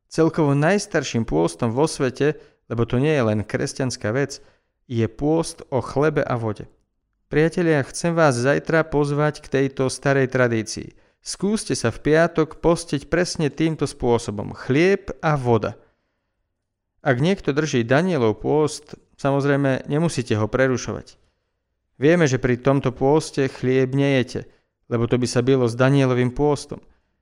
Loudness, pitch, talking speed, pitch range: -21 LUFS, 135 Hz, 135 wpm, 120-155 Hz